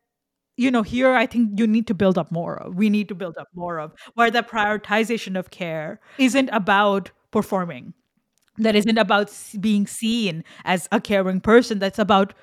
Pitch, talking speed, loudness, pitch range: 210 Hz, 185 wpm, -21 LUFS, 190-225 Hz